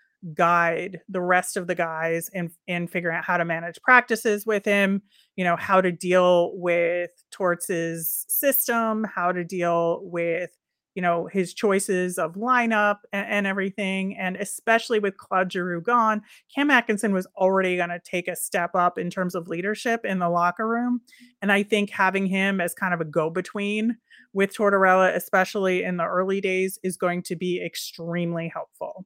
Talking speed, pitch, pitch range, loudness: 175 wpm, 185 Hz, 175-205 Hz, -23 LUFS